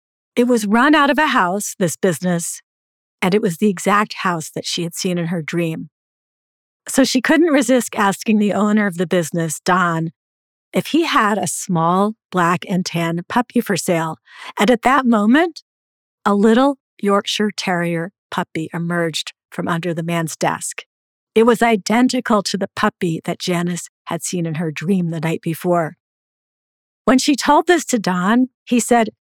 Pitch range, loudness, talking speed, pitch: 170-240 Hz, -18 LUFS, 170 wpm, 195 Hz